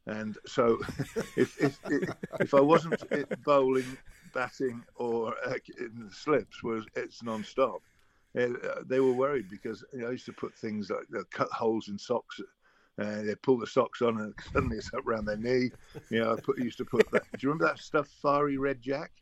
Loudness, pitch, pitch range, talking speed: -31 LUFS, 120 Hz, 110-130 Hz, 200 wpm